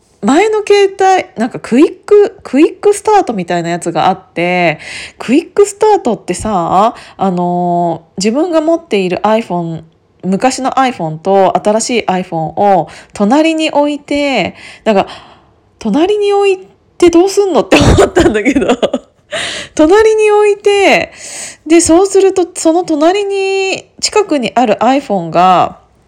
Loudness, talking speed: -11 LUFS, 300 characters per minute